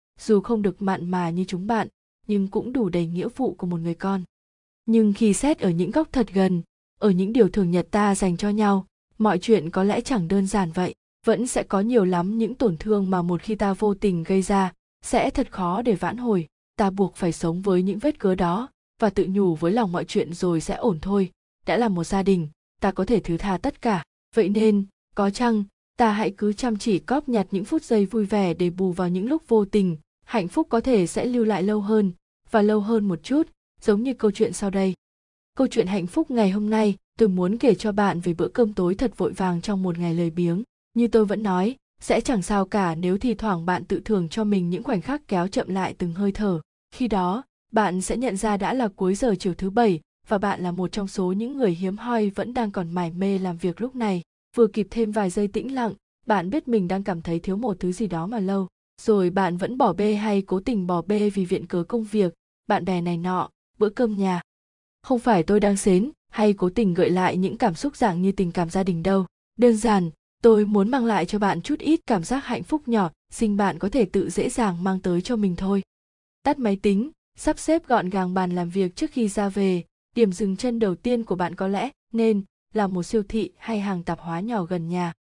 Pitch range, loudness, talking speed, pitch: 185-225 Hz, -23 LUFS, 245 wpm, 200 Hz